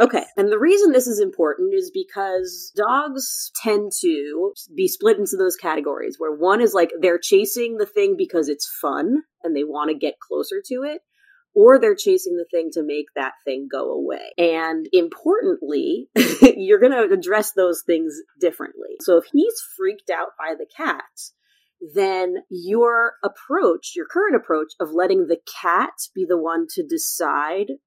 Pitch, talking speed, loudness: 255 Hz, 170 wpm, -20 LUFS